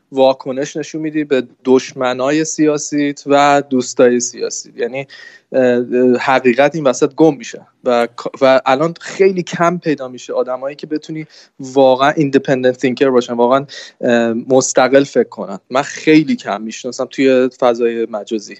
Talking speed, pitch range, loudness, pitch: 130 wpm, 125-155 Hz, -14 LUFS, 135 Hz